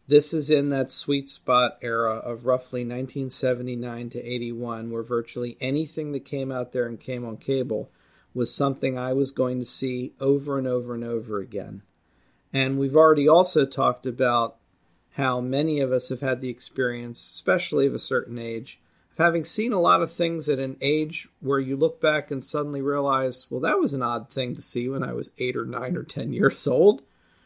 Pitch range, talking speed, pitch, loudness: 120-140 Hz, 195 wpm, 130 Hz, -25 LUFS